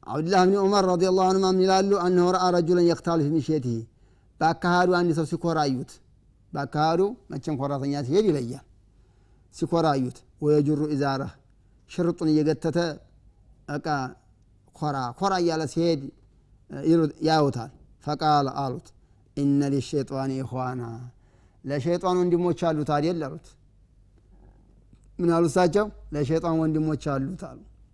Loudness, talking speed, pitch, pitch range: -24 LUFS, 140 wpm, 150 Hz, 130-170 Hz